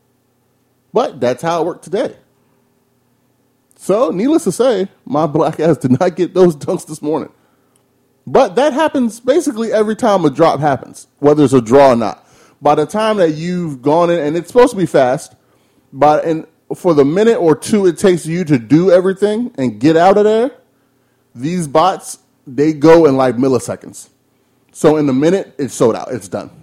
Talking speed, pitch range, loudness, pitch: 185 wpm, 140-190 Hz, -13 LUFS, 160 Hz